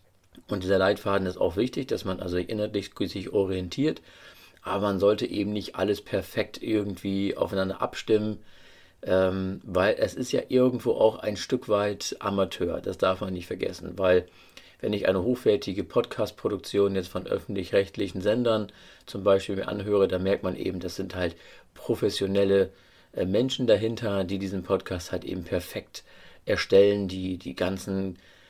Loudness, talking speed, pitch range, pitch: -27 LUFS, 150 wpm, 95-105 Hz, 95 Hz